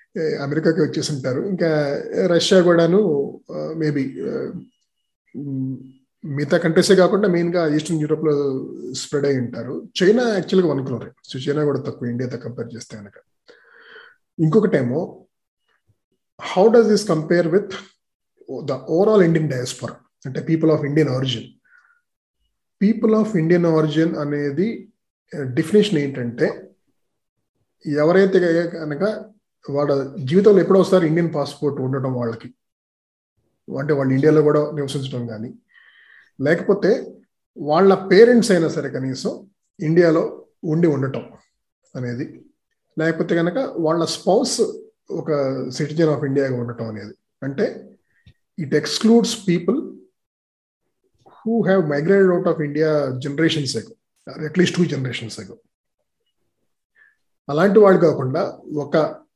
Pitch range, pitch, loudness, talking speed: 140-185 Hz, 155 Hz, -19 LUFS, 105 wpm